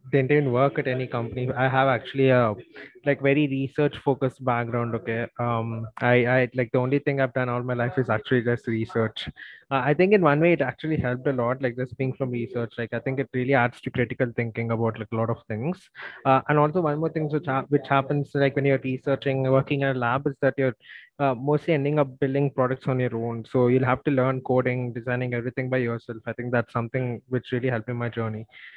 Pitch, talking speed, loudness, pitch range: 130 Hz, 235 wpm, -25 LUFS, 120-140 Hz